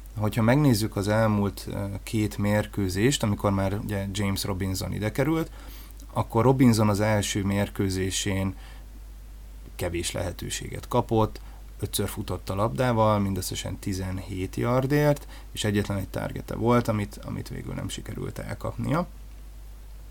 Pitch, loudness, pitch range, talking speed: 105 Hz, -27 LUFS, 100-115 Hz, 115 wpm